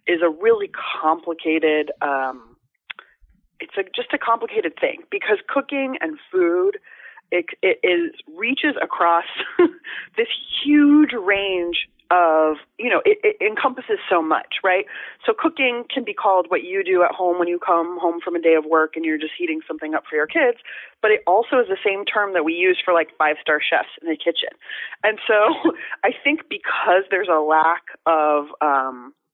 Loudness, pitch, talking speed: -20 LUFS, 215 Hz, 180 wpm